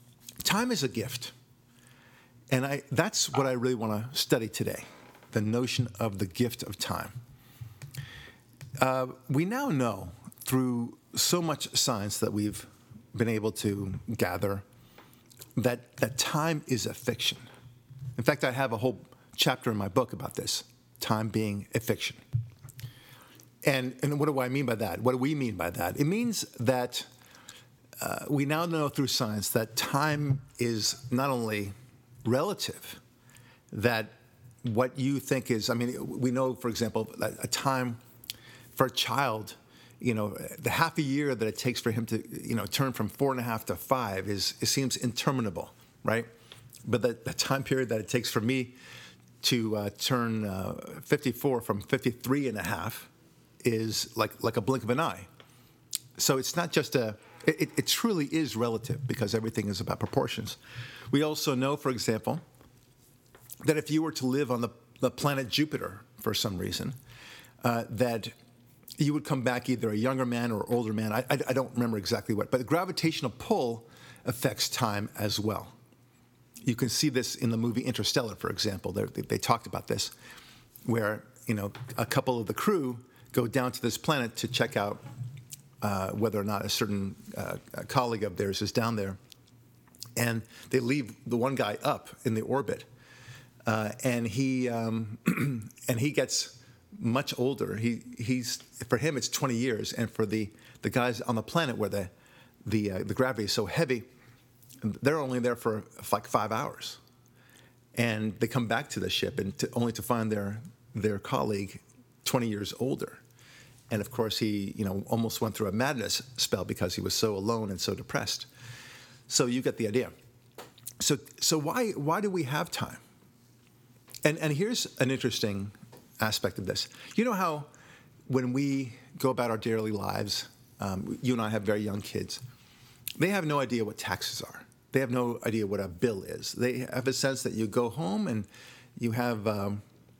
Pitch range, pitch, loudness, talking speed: 115-130 Hz, 125 Hz, -30 LUFS, 180 wpm